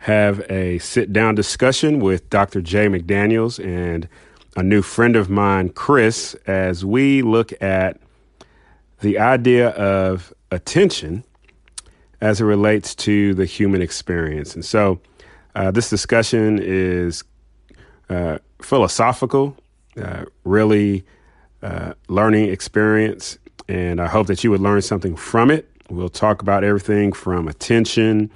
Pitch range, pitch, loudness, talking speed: 95-110 Hz, 100 Hz, -18 LUFS, 125 wpm